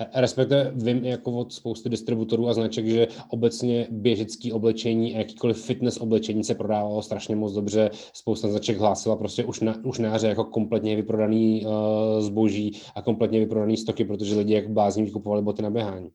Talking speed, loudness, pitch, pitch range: 170 wpm, -25 LUFS, 110 Hz, 105-115 Hz